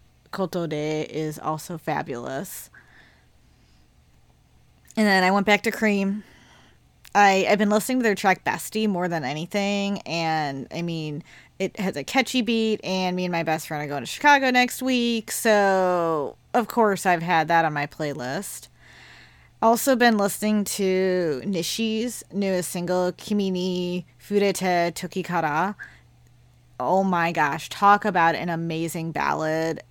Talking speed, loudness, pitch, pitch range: 140 wpm, -23 LUFS, 180 Hz, 155-205 Hz